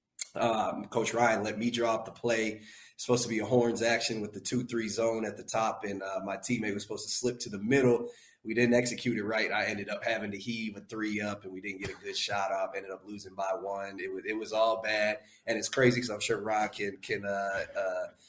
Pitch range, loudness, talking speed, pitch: 100-120 Hz, -30 LUFS, 255 wpm, 110 Hz